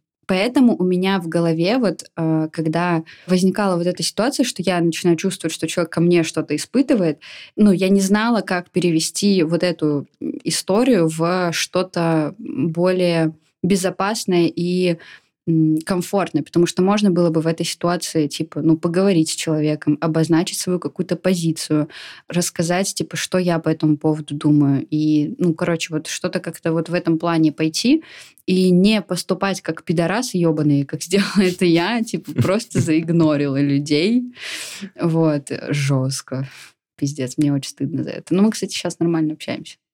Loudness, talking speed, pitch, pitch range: -19 LUFS, 150 wpm, 170 Hz, 155-185 Hz